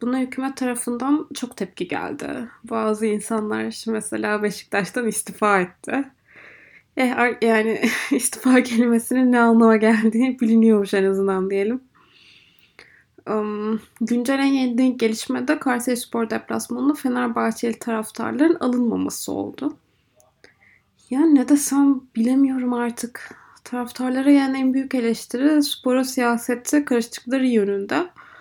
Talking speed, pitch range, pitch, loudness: 105 wpm, 225-260 Hz, 240 Hz, -21 LUFS